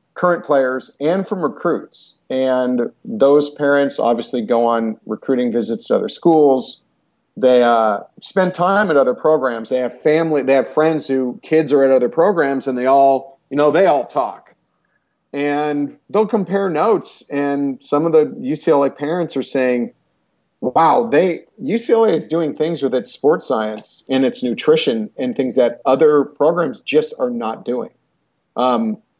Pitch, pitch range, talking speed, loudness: 140 Hz, 130-175 Hz, 160 wpm, -17 LUFS